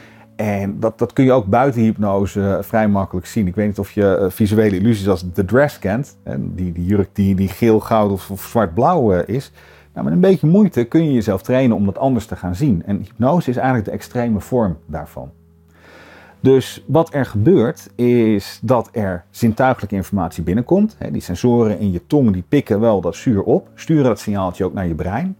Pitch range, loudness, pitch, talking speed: 95-120 Hz, -17 LUFS, 105 Hz, 200 wpm